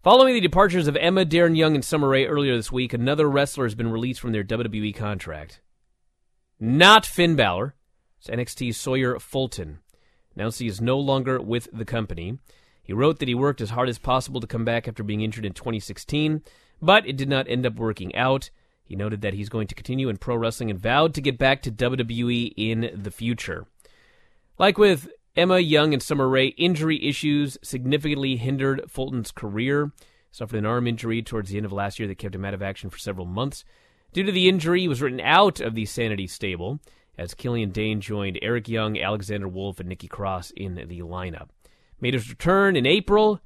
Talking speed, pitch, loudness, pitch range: 200 wpm, 120 Hz, -23 LUFS, 105-145 Hz